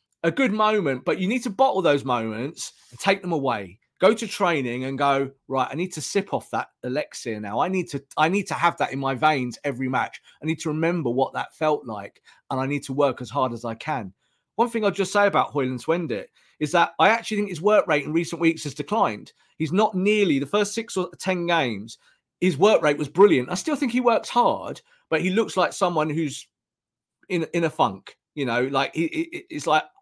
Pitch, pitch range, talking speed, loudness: 165 Hz, 135-205 Hz, 235 wpm, -23 LUFS